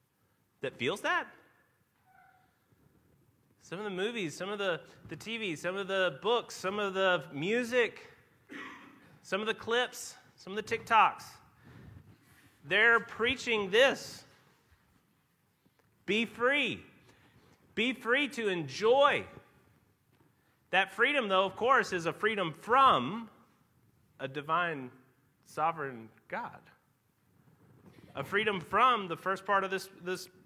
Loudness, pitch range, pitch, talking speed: -30 LUFS, 170-235 Hz, 195 Hz, 115 wpm